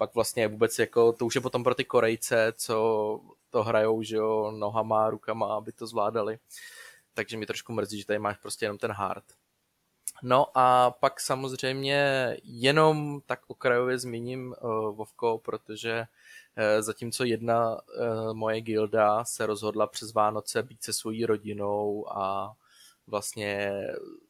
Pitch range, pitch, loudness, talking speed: 105-125 Hz, 110 Hz, -28 LUFS, 145 wpm